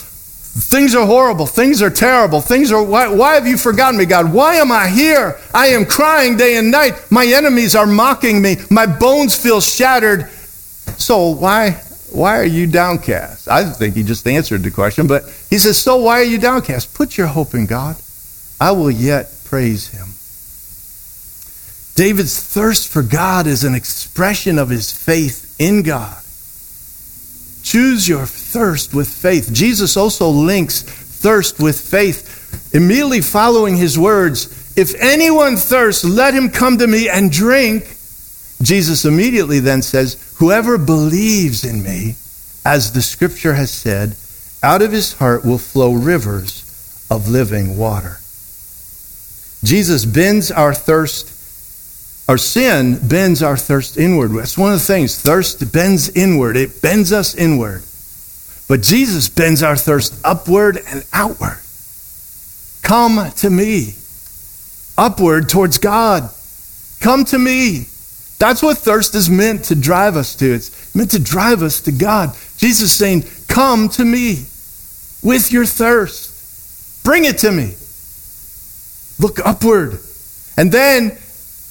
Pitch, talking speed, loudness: 165 Hz, 145 wpm, -12 LUFS